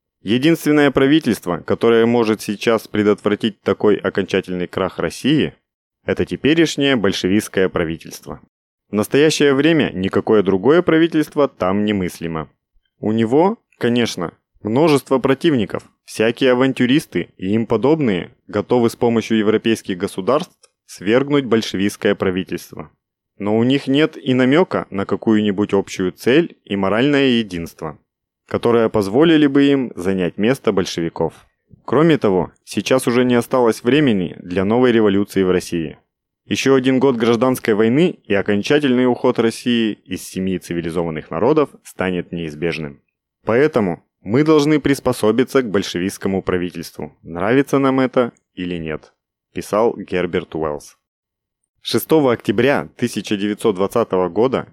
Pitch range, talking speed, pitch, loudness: 95-130 Hz, 115 wpm, 110 Hz, -17 LUFS